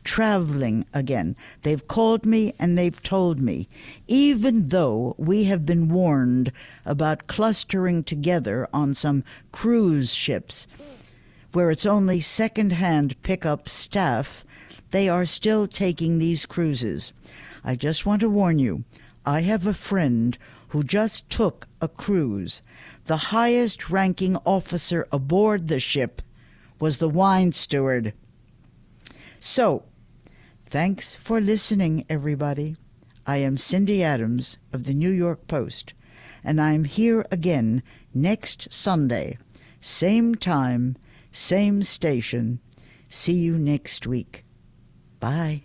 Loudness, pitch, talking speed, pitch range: -23 LUFS, 155 Hz, 120 wpm, 130-190 Hz